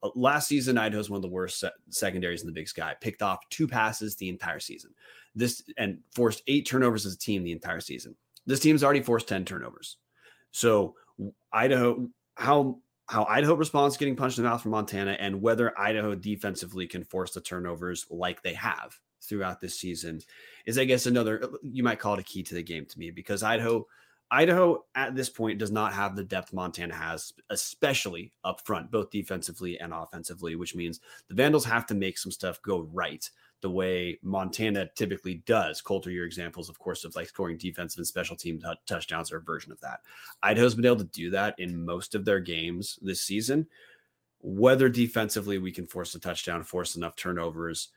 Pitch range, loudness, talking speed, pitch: 90-120 Hz, -29 LUFS, 195 wpm, 100 Hz